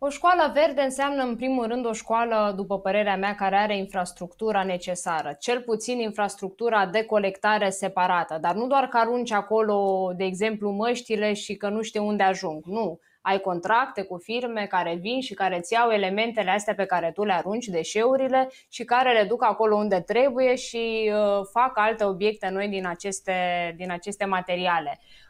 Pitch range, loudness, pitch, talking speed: 190-230 Hz, -25 LUFS, 210 Hz, 175 wpm